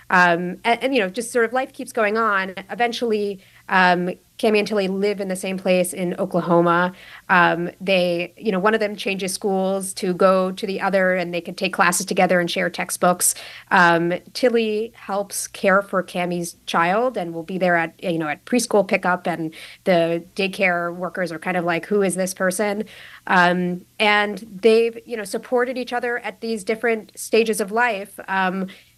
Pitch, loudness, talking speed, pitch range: 190 Hz, -20 LUFS, 190 wpm, 180-215 Hz